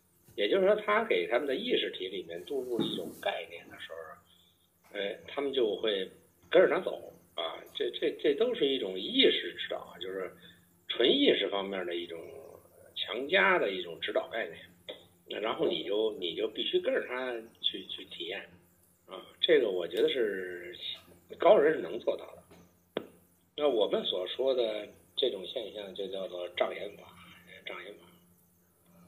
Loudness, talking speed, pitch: -31 LUFS, 230 characters per minute, 375 Hz